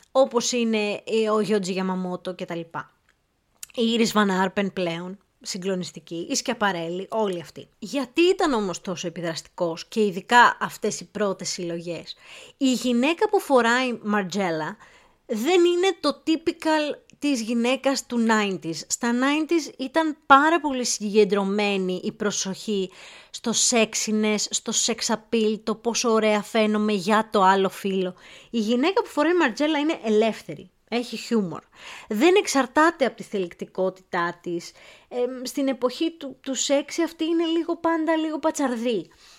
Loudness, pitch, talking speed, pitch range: -23 LUFS, 220 Hz, 130 wpm, 190-275 Hz